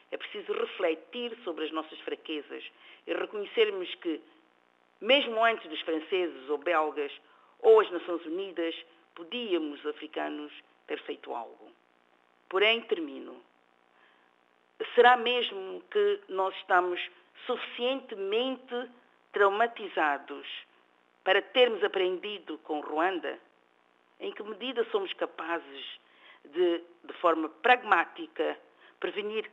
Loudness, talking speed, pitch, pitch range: -30 LUFS, 100 wpm, 185 Hz, 150-250 Hz